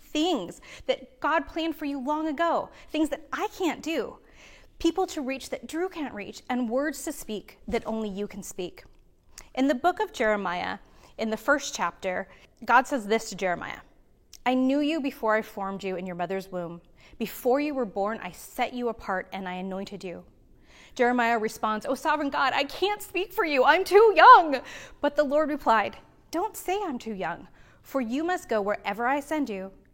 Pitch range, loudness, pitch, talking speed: 210-305 Hz, -26 LUFS, 260 Hz, 190 wpm